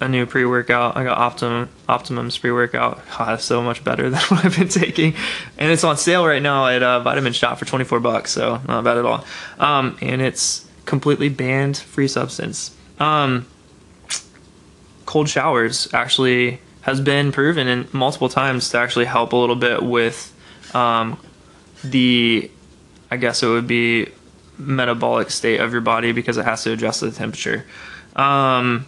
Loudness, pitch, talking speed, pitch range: -18 LUFS, 125 Hz, 165 wpm, 120-140 Hz